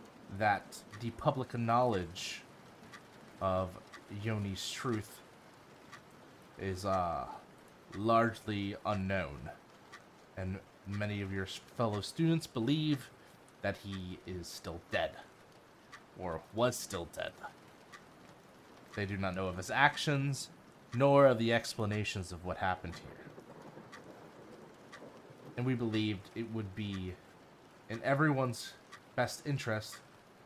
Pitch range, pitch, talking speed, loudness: 95-125 Hz, 105 Hz, 100 wpm, -35 LUFS